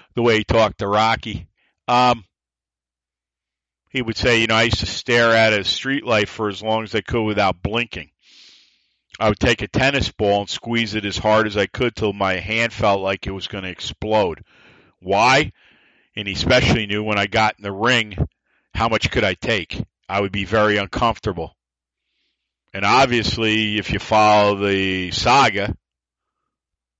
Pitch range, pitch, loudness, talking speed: 95-115 Hz, 105 Hz, -19 LUFS, 180 wpm